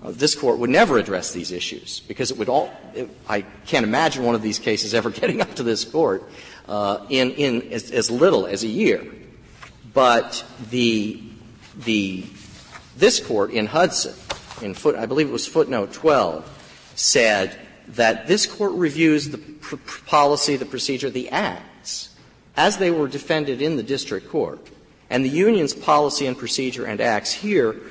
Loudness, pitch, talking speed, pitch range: -21 LUFS, 130 Hz, 170 wpm, 115-150 Hz